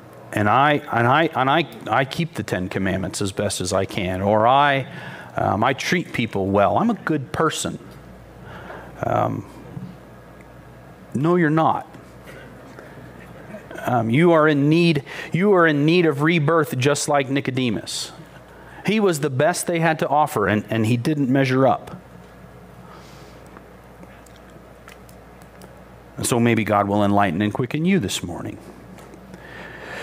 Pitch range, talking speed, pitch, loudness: 95-160 Hz, 140 wpm, 130 Hz, -20 LUFS